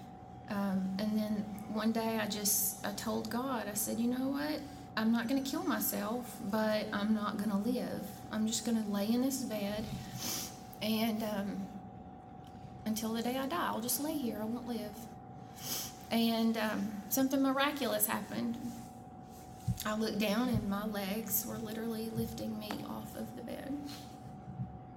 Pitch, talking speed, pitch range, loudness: 220 Hz, 155 wpm, 205-245 Hz, -35 LUFS